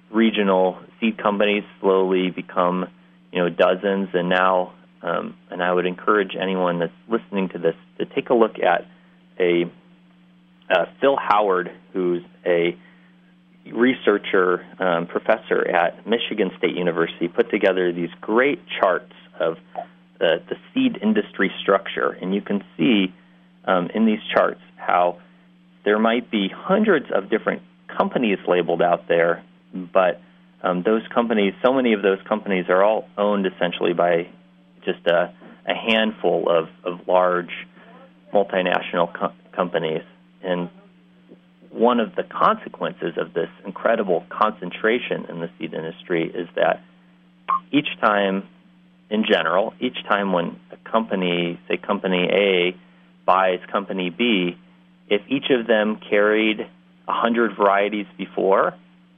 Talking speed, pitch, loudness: 130 wpm, 90 Hz, -21 LUFS